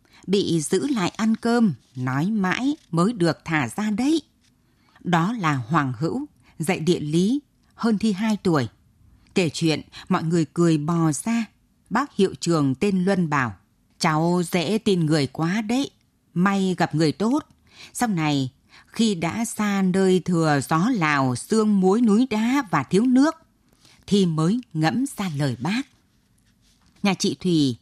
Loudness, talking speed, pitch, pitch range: -22 LUFS, 155 wpm, 180 Hz, 155-215 Hz